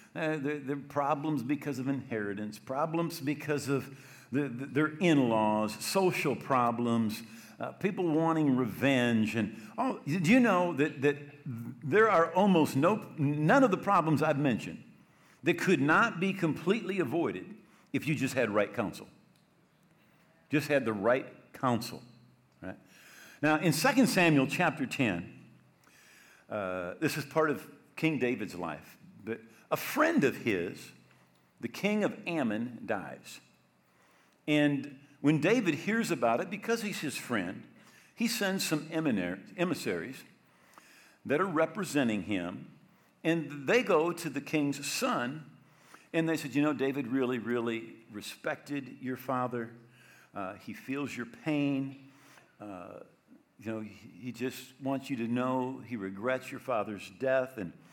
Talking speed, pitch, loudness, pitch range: 140 wpm, 140 Hz, -31 LUFS, 120-160 Hz